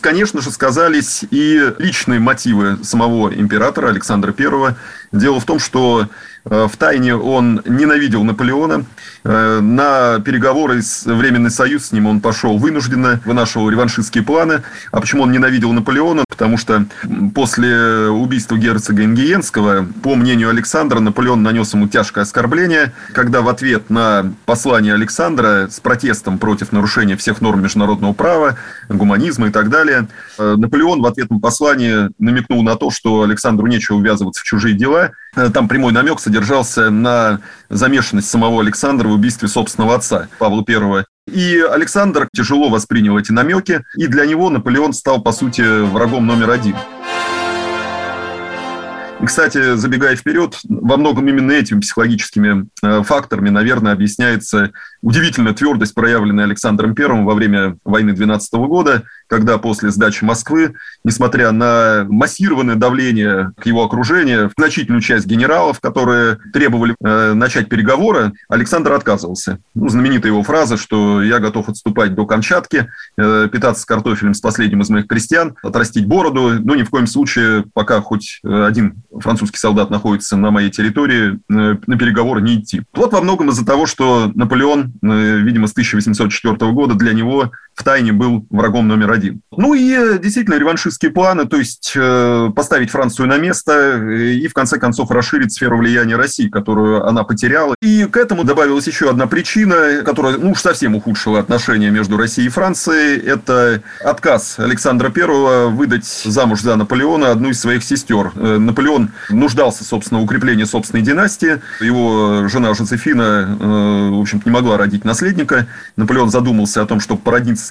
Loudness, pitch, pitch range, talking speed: -13 LUFS, 115 Hz, 105-125 Hz, 150 wpm